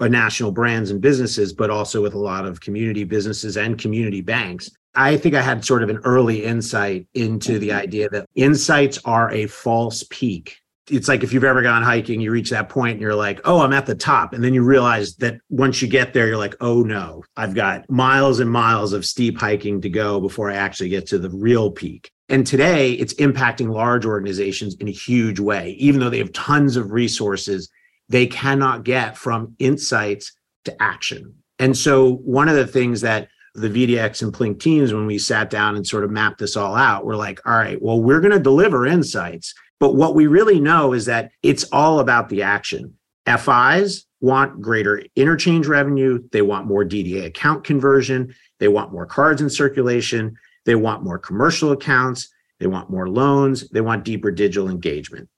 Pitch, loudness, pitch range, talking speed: 120 Hz, -18 LUFS, 105-135 Hz, 200 wpm